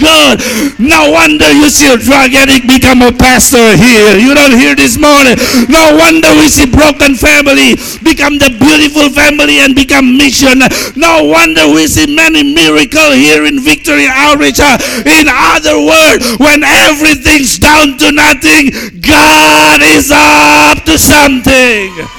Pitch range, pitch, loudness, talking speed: 245-300 Hz, 280 Hz, -3 LUFS, 140 wpm